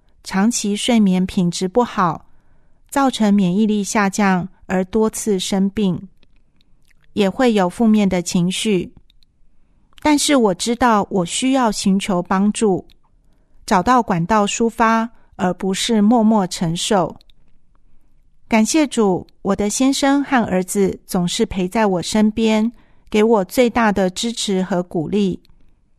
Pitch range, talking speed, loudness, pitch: 190-230 Hz, 185 characters per minute, -17 LUFS, 205 Hz